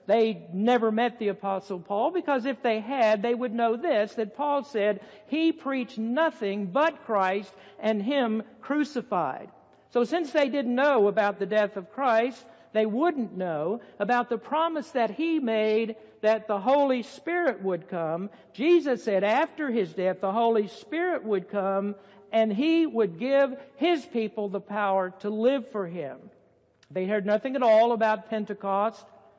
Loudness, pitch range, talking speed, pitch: -27 LUFS, 205-270 Hz, 160 wpm, 225 Hz